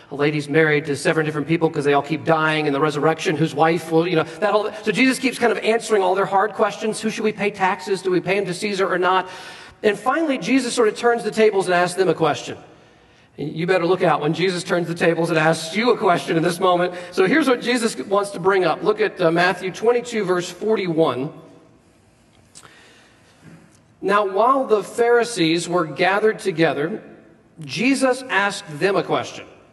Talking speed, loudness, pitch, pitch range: 205 wpm, -19 LUFS, 185 Hz, 165-215 Hz